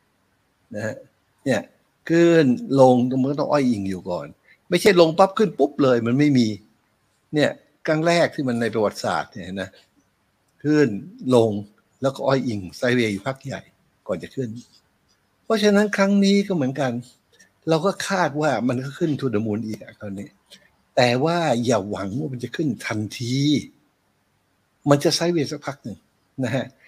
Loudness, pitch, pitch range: -21 LUFS, 130 Hz, 115-155 Hz